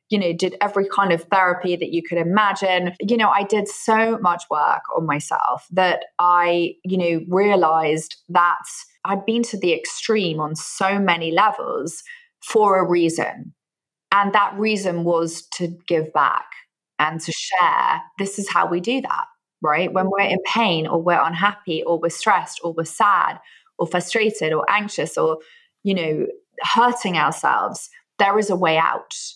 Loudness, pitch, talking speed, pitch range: -20 LUFS, 185 Hz, 170 wpm, 170-215 Hz